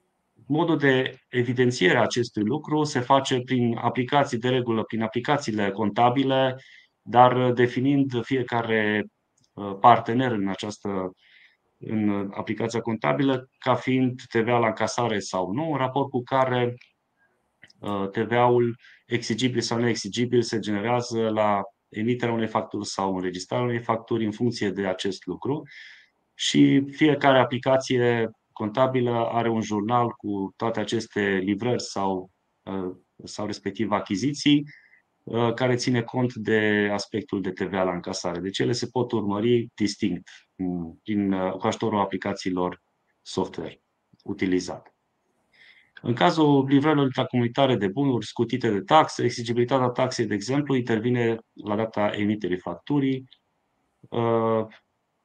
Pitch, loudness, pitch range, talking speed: 115 Hz, -24 LUFS, 105-125 Hz, 115 wpm